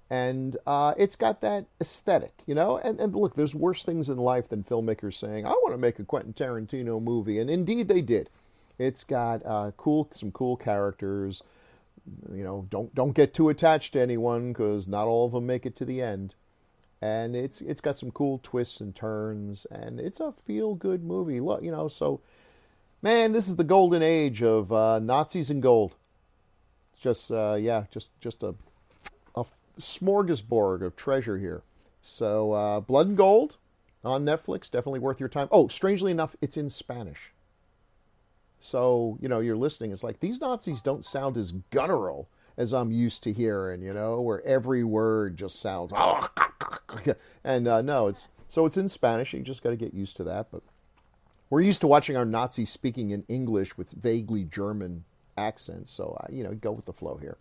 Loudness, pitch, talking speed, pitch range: -27 LUFS, 120 Hz, 190 wpm, 105-140 Hz